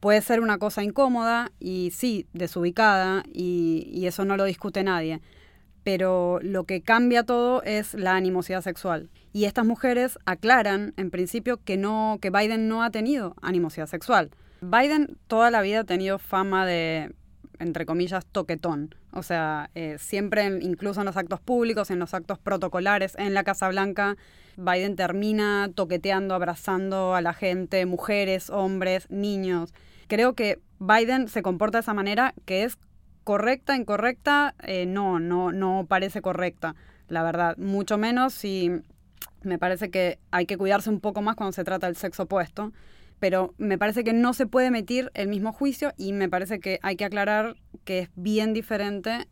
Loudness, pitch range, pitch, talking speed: -25 LUFS, 185-215 Hz, 195 Hz, 170 wpm